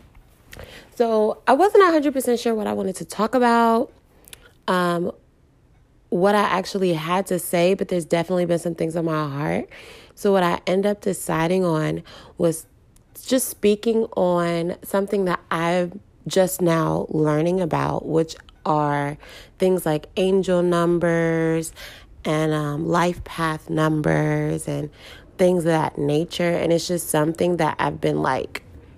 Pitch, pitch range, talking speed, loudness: 175 Hz, 160-190 Hz, 145 wpm, -21 LUFS